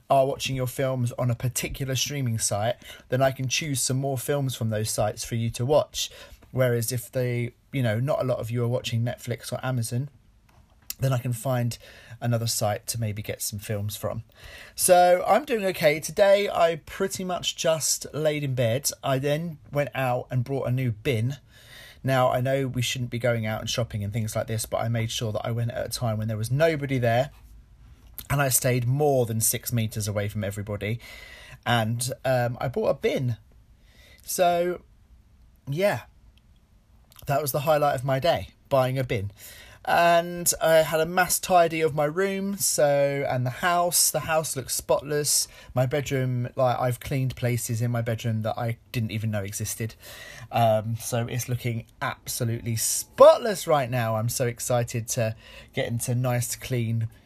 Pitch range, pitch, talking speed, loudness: 115-140 Hz, 125 Hz, 185 wpm, -25 LUFS